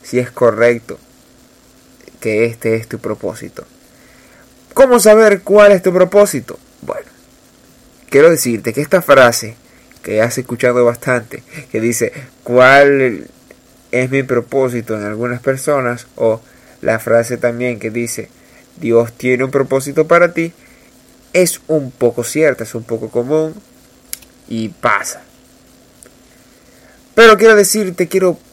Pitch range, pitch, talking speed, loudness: 120-155 Hz, 125 Hz, 125 wpm, -13 LUFS